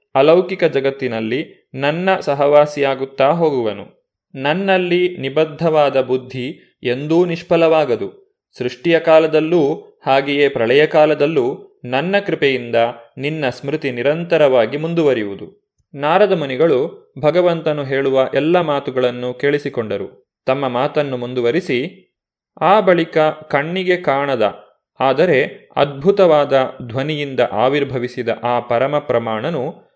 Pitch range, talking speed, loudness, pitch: 130-170 Hz, 80 wpm, -16 LUFS, 145 Hz